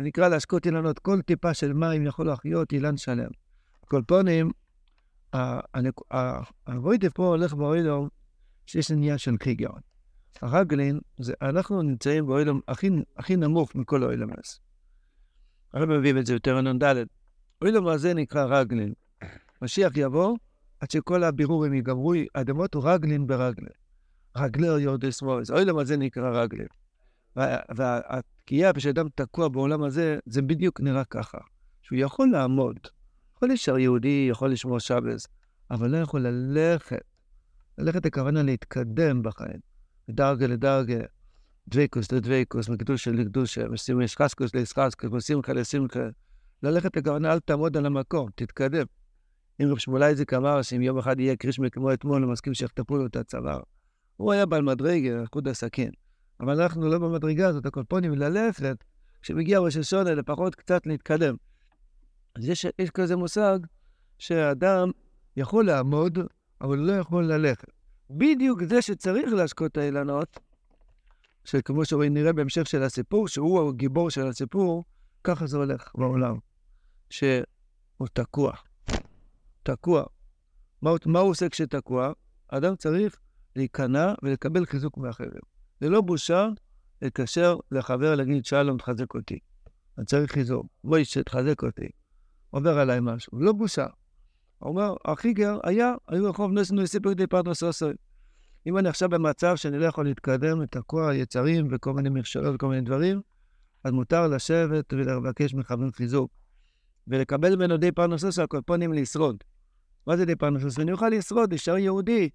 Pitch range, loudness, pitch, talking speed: 130-170 Hz, -26 LUFS, 145 Hz, 140 wpm